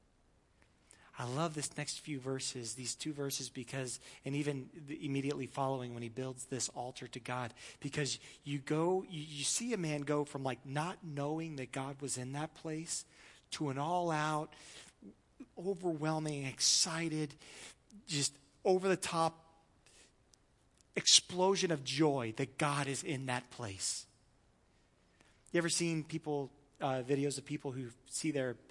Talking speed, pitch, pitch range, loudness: 150 wpm, 145 Hz, 130-155 Hz, -37 LUFS